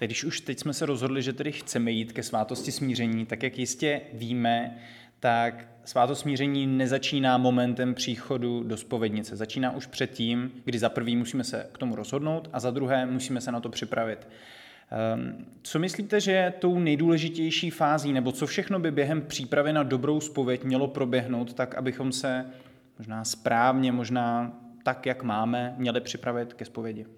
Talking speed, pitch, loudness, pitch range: 165 wpm, 130 Hz, -28 LUFS, 120-140 Hz